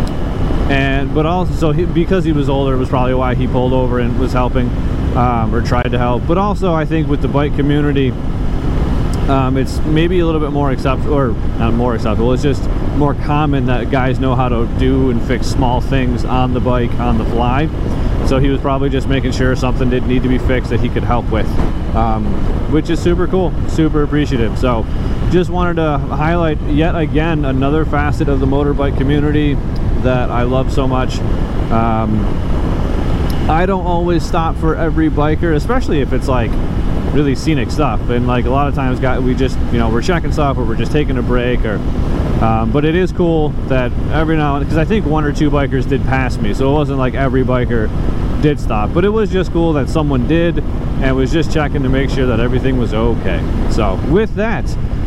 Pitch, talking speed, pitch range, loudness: 130 Hz, 210 wpm, 120-150 Hz, -15 LUFS